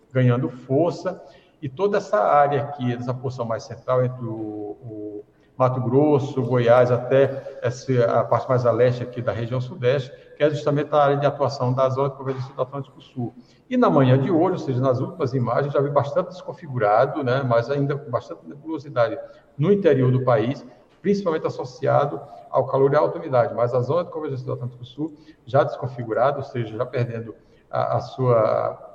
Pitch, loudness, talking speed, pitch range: 130 Hz, -22 LUFS, 190 wpm, 120-145 Hz